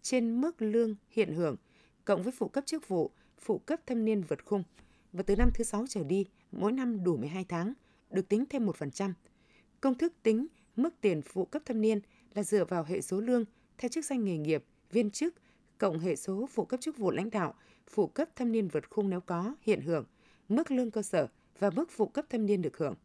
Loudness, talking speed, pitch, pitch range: -33 LUFS, 225 wpm, 215 Hz, 190-245 Hz